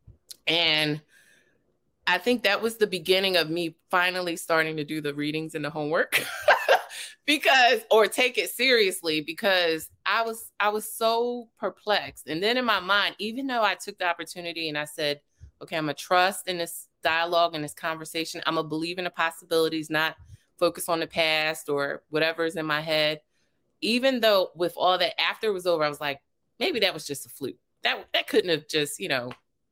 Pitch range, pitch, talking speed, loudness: 155-200 Hz, 170 Hz, 190 wpm, -25 LUFS